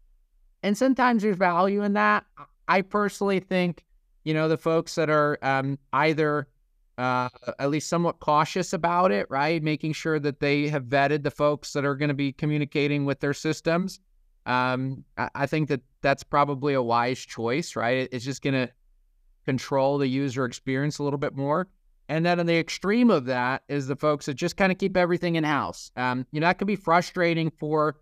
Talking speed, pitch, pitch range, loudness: 195 wpm, 150 Hz, 135-170 Hz, -25 LUFS